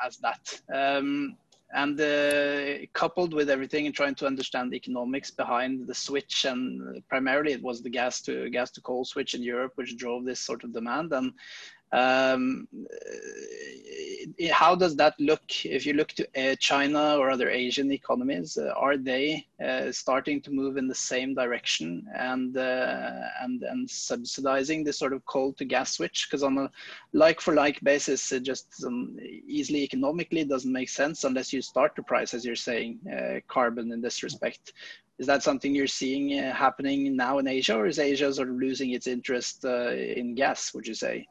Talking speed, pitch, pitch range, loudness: 185 wpm, 135 Hz, 130-145 Hz, -28 LUFS